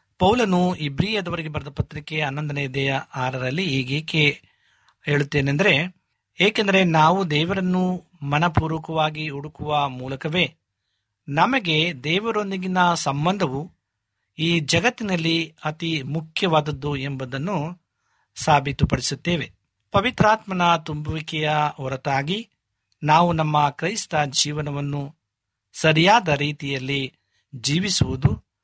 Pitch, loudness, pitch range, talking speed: 150 Hz, -22 LUFS, 140-175 Hz, 70 wpm